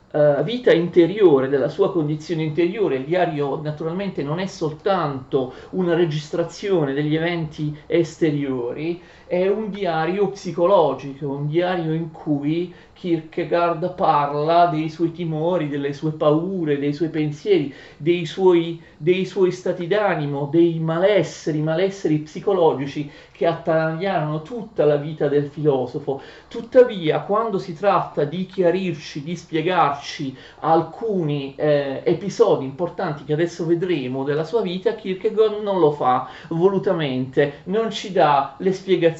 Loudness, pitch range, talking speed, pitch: -21 LUFS, 150-180 Hz, 125 wpm, 165 Hz